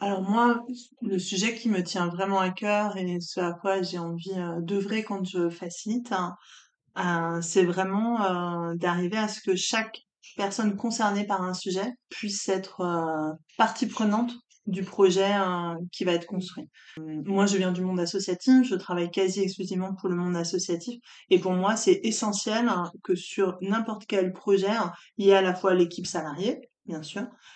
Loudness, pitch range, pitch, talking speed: -27 LUFS, 180-215 Hz, 190 Hz, 165 wpm